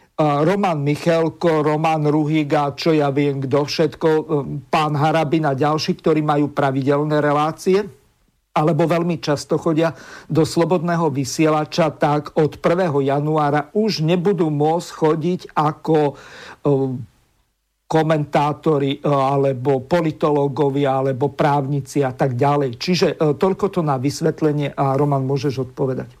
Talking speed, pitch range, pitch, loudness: 115 wpm, 140-160 Hz, 150 Hz, -19 LUFS